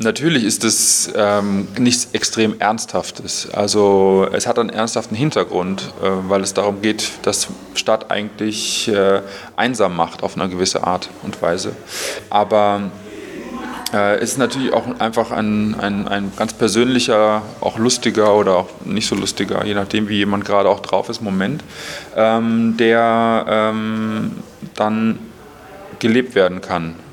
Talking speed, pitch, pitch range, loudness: 145 wpm, 110 Hz, 100-115 Hz, -17 LUFS